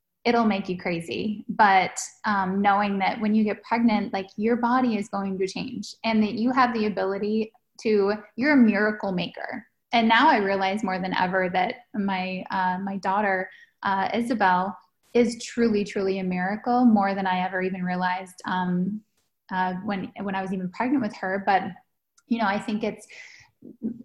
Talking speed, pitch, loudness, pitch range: 175 wpm, 205 Hz, -24 LUFS, 190-225 Hz